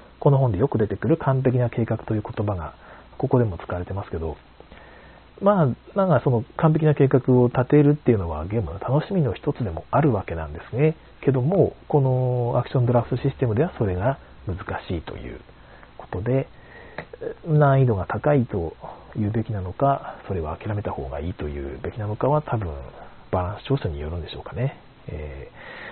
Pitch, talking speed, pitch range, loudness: 120 Hz, 370 characters per minute, 95-140 Hz, -23 LUFS